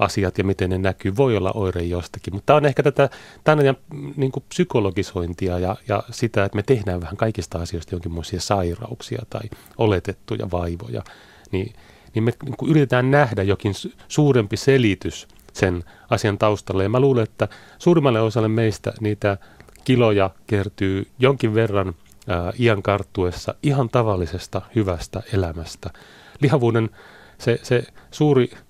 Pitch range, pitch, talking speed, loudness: 95-125 Hz, 105 Hz, 140 wpm, -21 LUFS